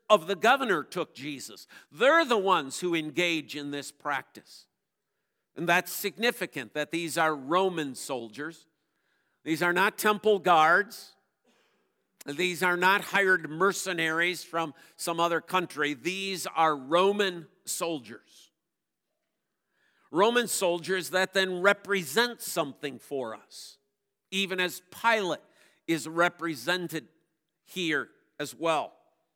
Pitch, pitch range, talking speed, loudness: 175 Hz, 160-190 Hz, 110 wpm, -27 LUFS